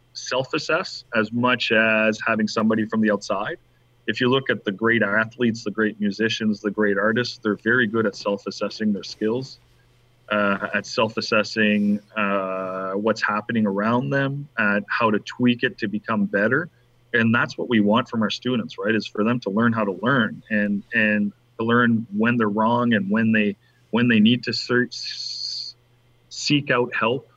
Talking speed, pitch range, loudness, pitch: 180 wpm, 105-120 Hz, -22 LUFS, 115 Hz